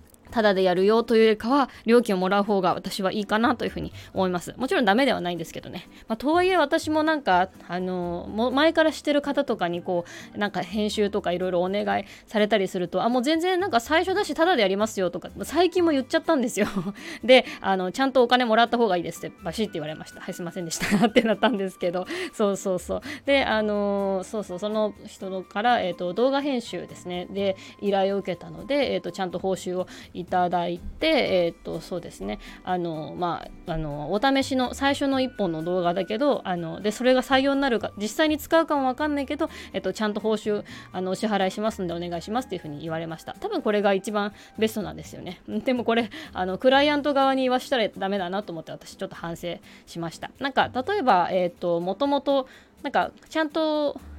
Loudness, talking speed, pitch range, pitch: -24 LUFS, 450 characters per minute, 180-265 Hz, 210 Hz